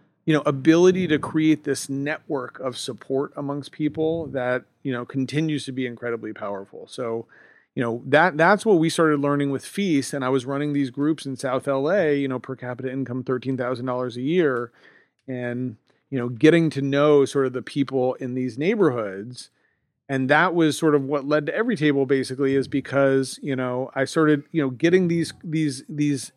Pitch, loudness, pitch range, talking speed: 140 Hz, -23 LUFS, 130-150 Hz, 195 wpm